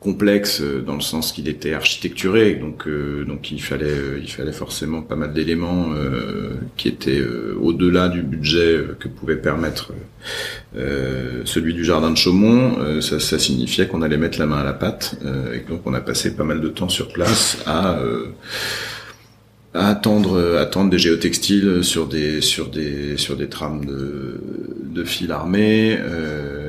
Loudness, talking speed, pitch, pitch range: -20 LUFS, 170 wpm, 80 Hz, 70-90 Hz